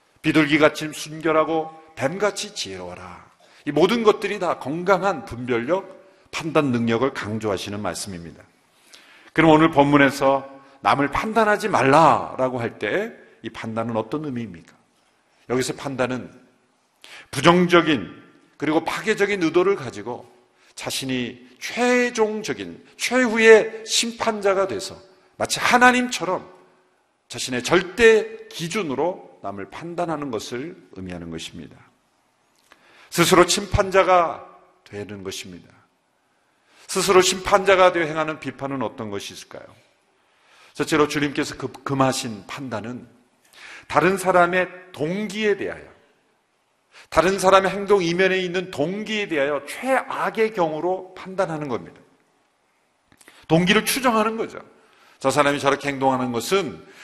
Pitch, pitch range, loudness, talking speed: 155 Hz, 130-195 Hz, -21 LUFS, 270 characters per minute